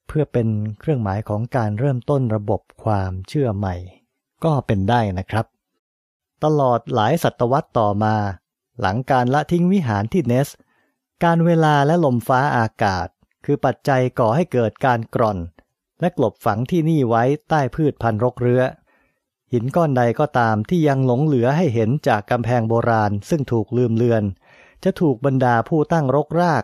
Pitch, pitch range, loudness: 125 Hz, 110-145 Hz, -19 LUFS